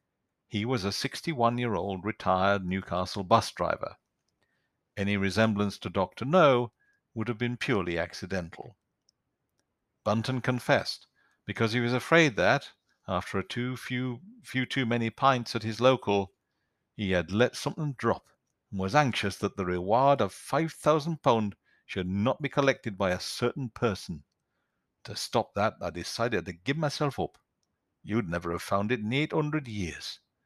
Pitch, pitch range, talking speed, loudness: 115 Hz, 100-130 Hz, 160 wpm, -29 LUFS